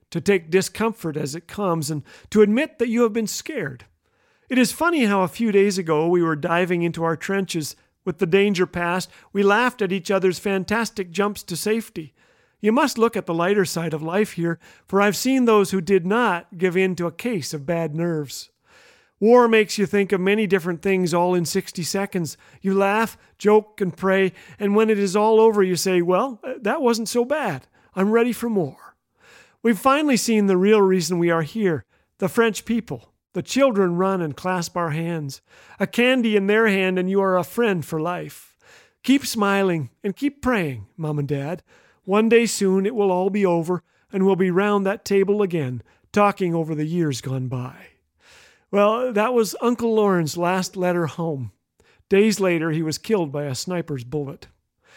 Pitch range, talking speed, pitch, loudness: 170-215 Hz, 195 wpm, 195 Hz, -21 LUFS